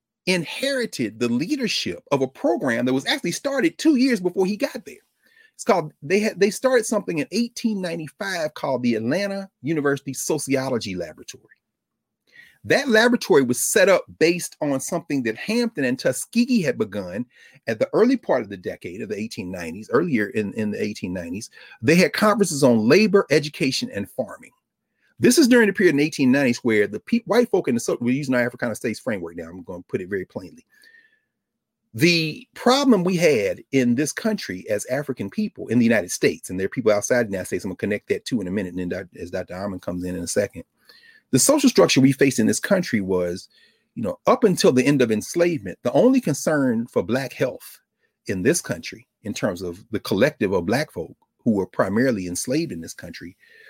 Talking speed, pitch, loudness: 200 wpm, 170 Hz, -21 LUFS